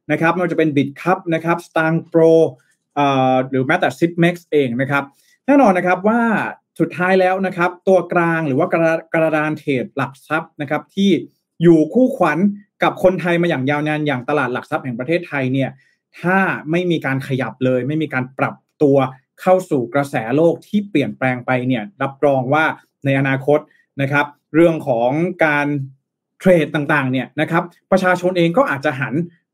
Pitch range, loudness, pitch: 140-175 Hz, -17 LUFS, 155 Hz